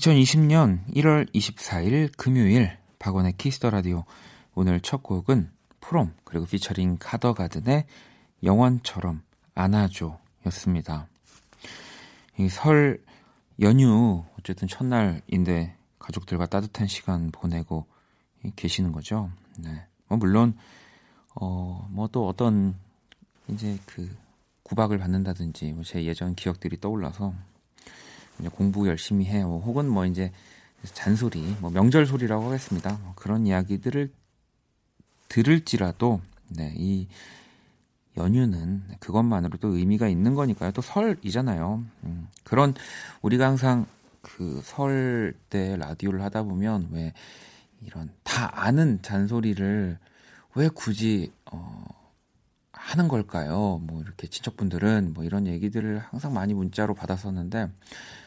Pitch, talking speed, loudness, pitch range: 100 Hz, 245 characters per minute, -25 LUFS, 90-115 Hz